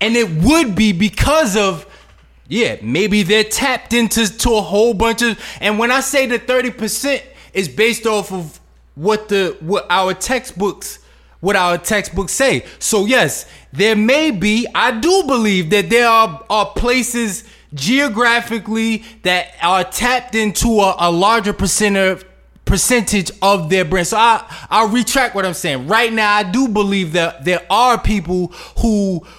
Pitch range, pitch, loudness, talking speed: 190-235 Hz, 215 Hz, -15 LUFS, 160 wpm